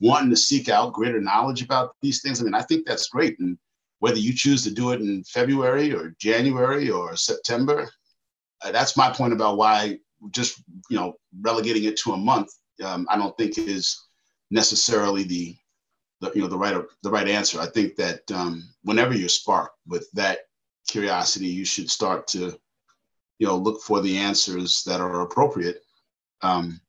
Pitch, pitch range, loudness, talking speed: 110 Hz, 90-135 Hz, -23 LUFS, 180 wpm